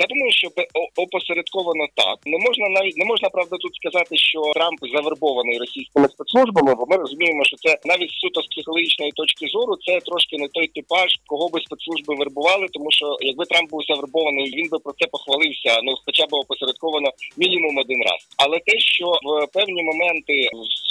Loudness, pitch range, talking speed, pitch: -19 LUFS, 145-180 Hz, 180 wpm, 160 Hz